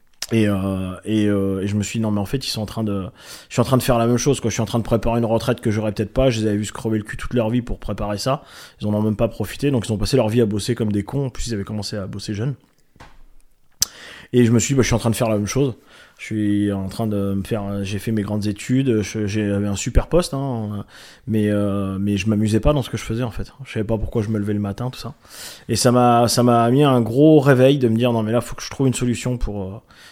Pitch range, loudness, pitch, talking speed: 105-125 Hz, -20 LUFS, 110 Hz, 315 wpm